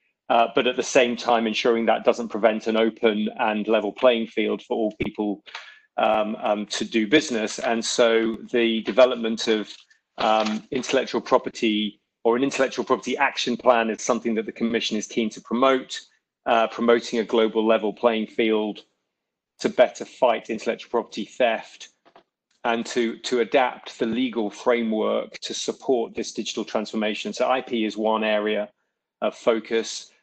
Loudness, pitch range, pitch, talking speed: -23 LUFS, 110-120 Hz, 115 Hz, 155 wpm